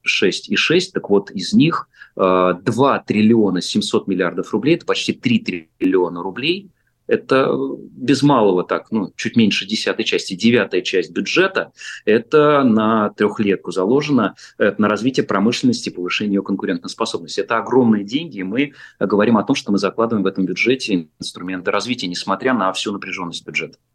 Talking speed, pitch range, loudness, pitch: 155 wpm, 95-130 Hz, -18 LUFS, 105 Hz